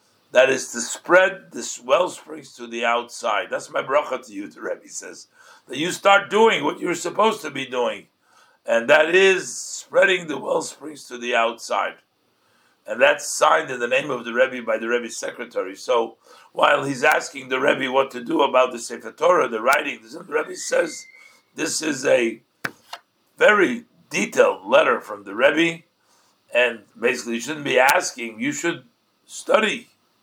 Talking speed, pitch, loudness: 170 wpm, 170 Hz, -20 LUFS